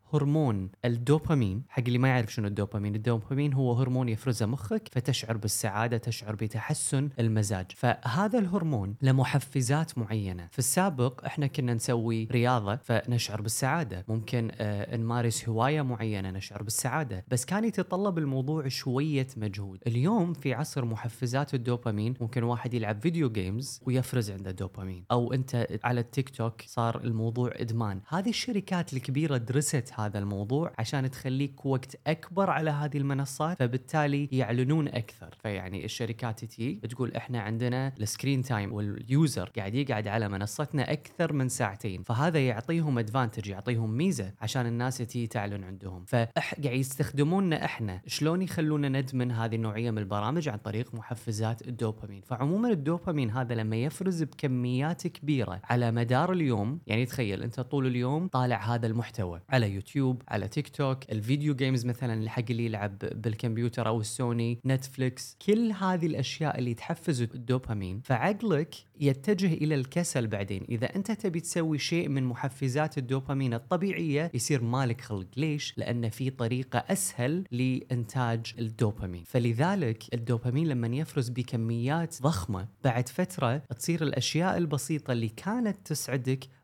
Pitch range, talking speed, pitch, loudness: 115-145 Hz, 135 wpm, 125 Hz, -30 LUFS